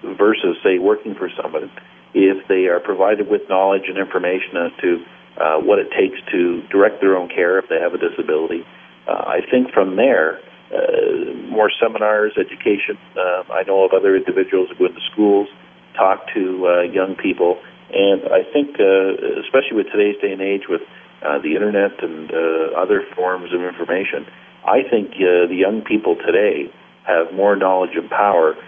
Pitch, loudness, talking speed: 360 Hz, -17 LUFS, 180 wpm